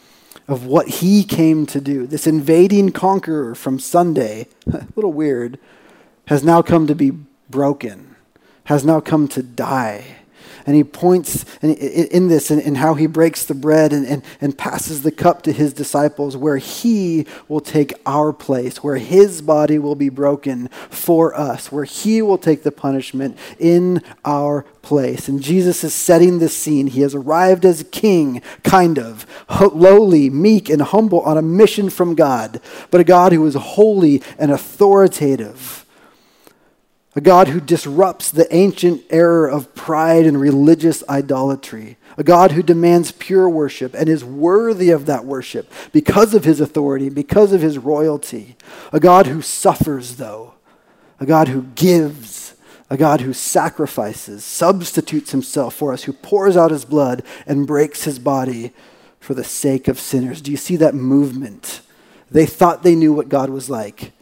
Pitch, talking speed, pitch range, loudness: 150 Hz, 165 wpm, 140-175 Hz, -15 LUFS